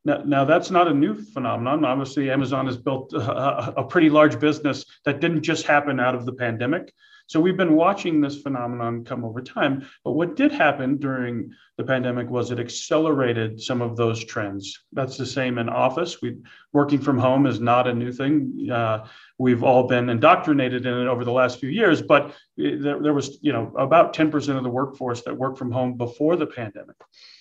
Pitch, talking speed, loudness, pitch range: 130 Hz, 200 wpm, -22 LUFS, 125-145 Hz